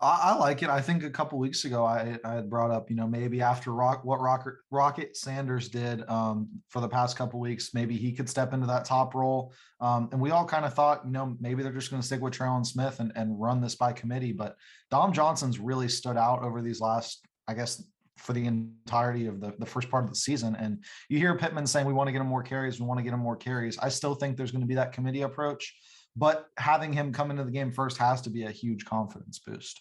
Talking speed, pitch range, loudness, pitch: 260 wpm, 120-135 Hz, -29 LUFS, 125 Hz